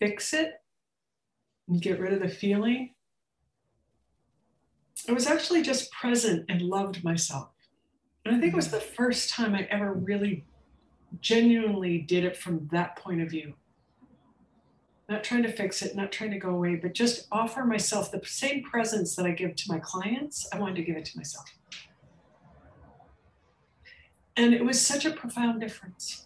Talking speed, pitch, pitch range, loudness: 165 wpm, 205 Hz, 180-235 Hz, -28 LUFS